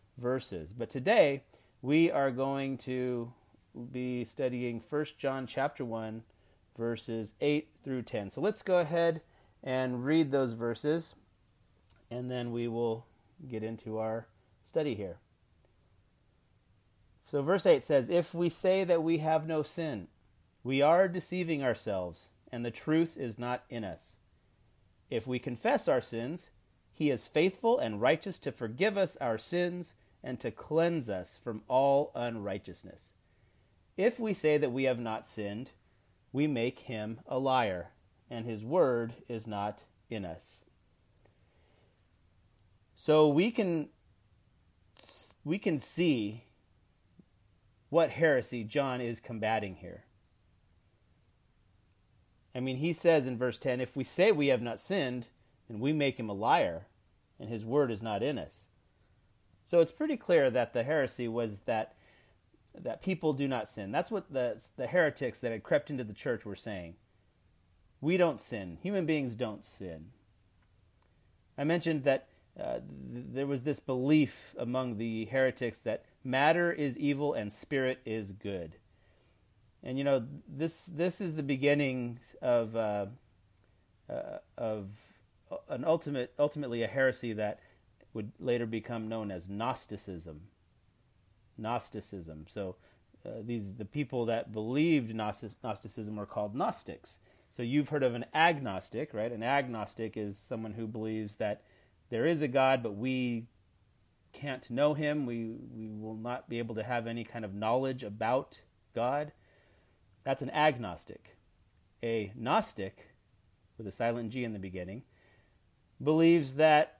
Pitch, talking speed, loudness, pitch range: 115 Hz, 145 wpm, -33 LUFS, 100-140 Hz